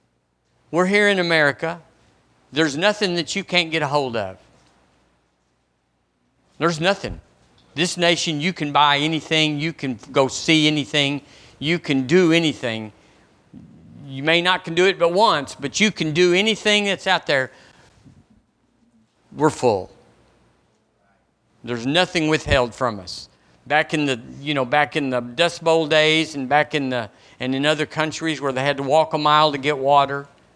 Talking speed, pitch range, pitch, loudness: 160 wpm, 130-165 Hz, 150 Hz, -19 LUFS